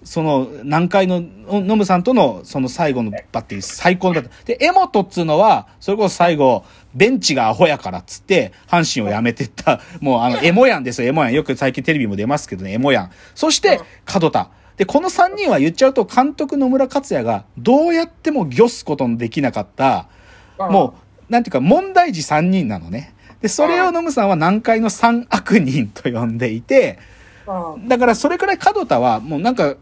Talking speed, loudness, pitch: 370 characters per minute, -16 LUFS, 195 Hz